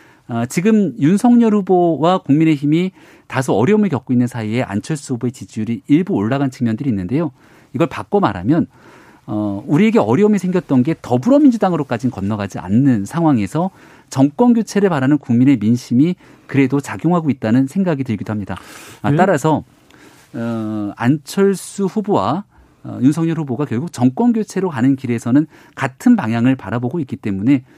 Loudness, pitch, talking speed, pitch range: -16 LUFS, 140 Hz, 360 characters per minute, 120-180 Hz